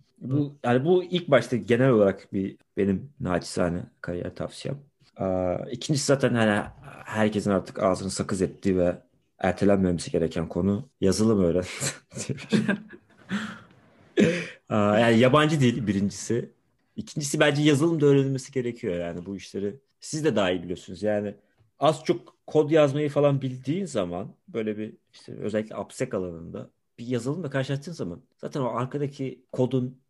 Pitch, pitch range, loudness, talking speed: 120 Hz, 100-140 Hz, -26 LUFS, 135 wpm